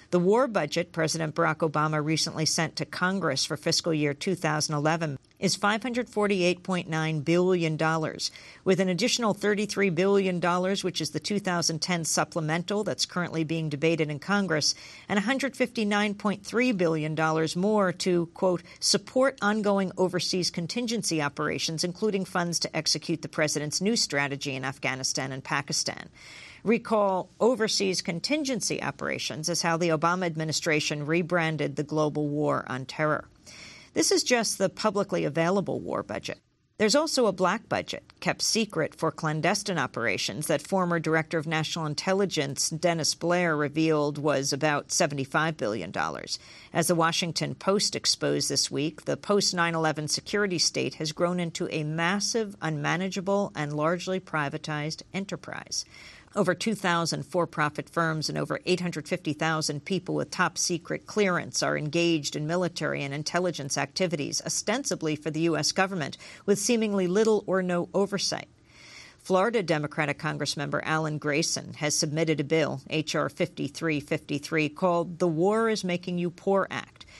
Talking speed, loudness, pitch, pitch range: 135 wpm, -27 LUFS, 170 Hz, 155-190 Hz